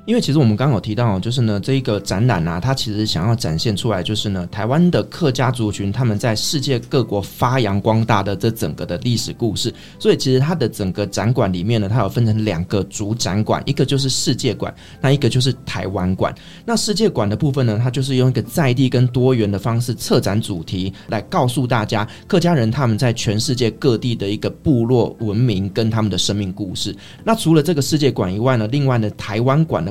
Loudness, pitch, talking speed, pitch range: -18 LUFS, 115 Hz, 340 characters per minute, 105-135 Hz